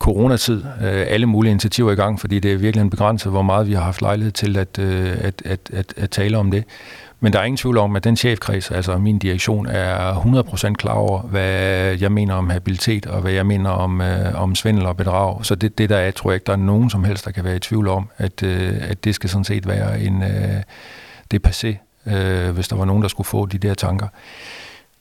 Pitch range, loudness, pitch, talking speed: 95-105 Hz, -19 LUFS, 100 Hz, 230 wpm